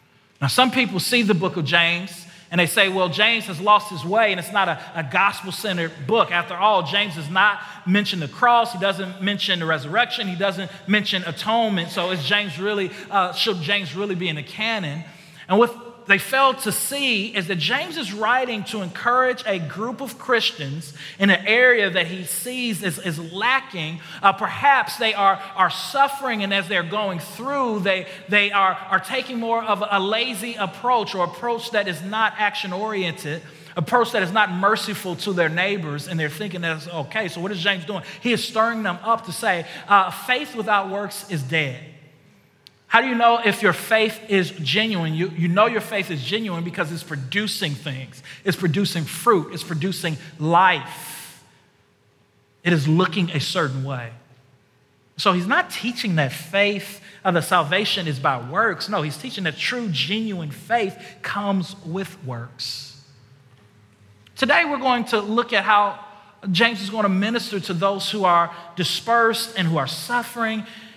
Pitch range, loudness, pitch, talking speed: 170-215 Hz, -21 LUFS, 195 Hz, 180 wpm